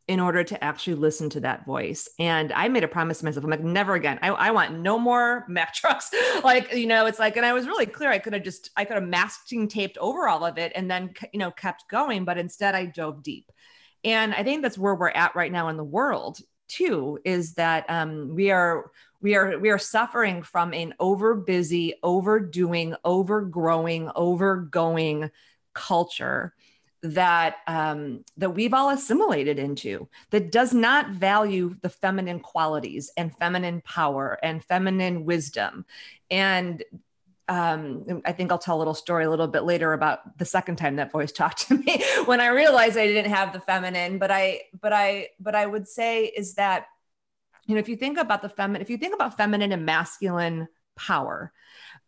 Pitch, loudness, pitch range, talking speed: 185 Hz, -24 LUFS, 165-210 Hz, 190 wpm